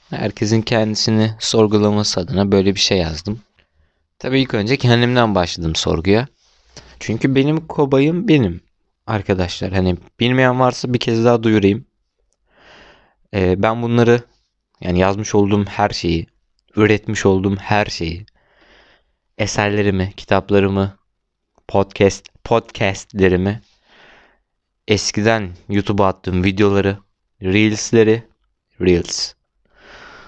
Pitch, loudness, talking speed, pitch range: 105 Hz, -17 LUFS, 95 wpm, 95-115 Hz